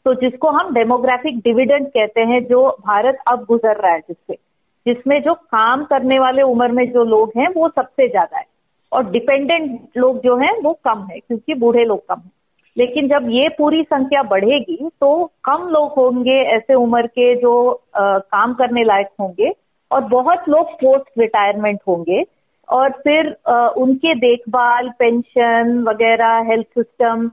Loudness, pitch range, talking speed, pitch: -15 LUFS, 235-285 Hz, 165 wpm, 250 Hz